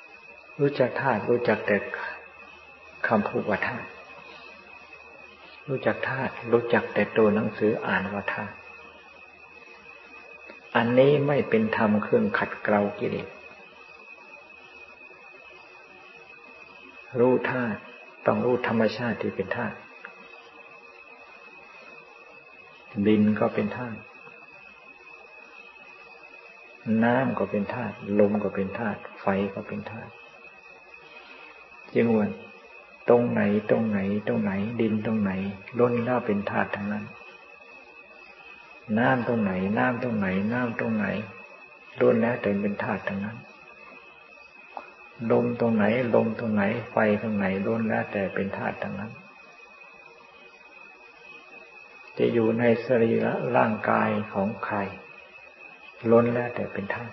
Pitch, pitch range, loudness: 110 Hz, 100-120 Hz, -26 LUFS